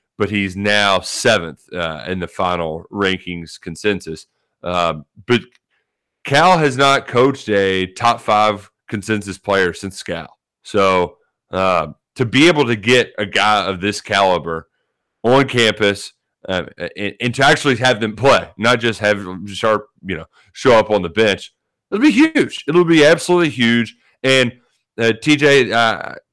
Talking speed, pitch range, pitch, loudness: 155 wpm, 95-125 Hz, 105 Hz, -16 LUFS